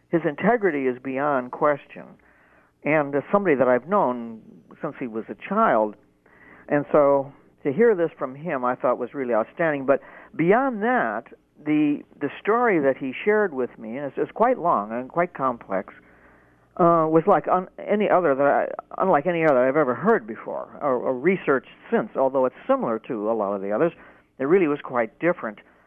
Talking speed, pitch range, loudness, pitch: 185 wpm, 130-180 Hz, -23 LUFS, 145 Hz